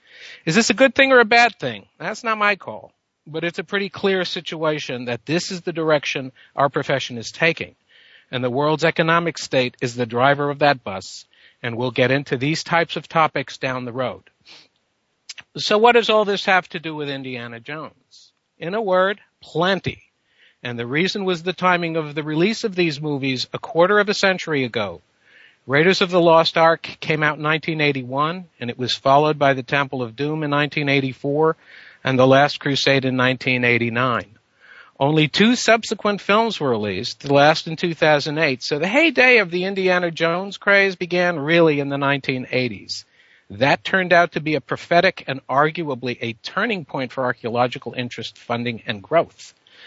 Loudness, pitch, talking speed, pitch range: -19 LUFS, 155 Hz, 180 wpm, 130-180 Hz